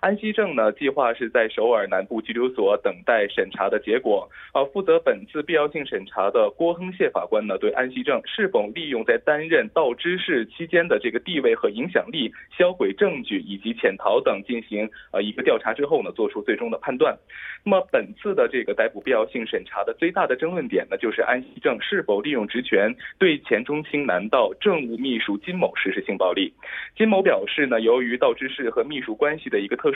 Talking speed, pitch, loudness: 325 characters per minute, 220 Hz, -23 LUFS